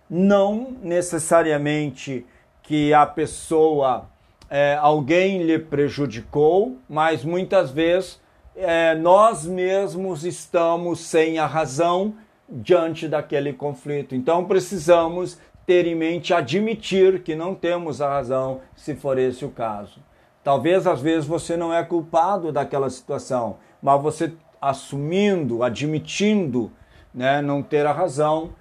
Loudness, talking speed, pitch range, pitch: -21 LUFS, 115 wpm, 145-175 Hz, 160 Hz